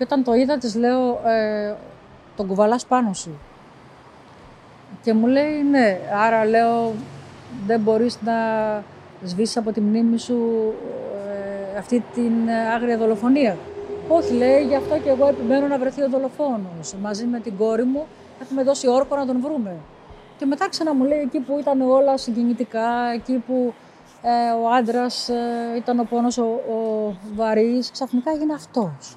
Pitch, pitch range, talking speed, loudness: 235 Hz, 220-265 Hz, 145 wpm, -21 LUFS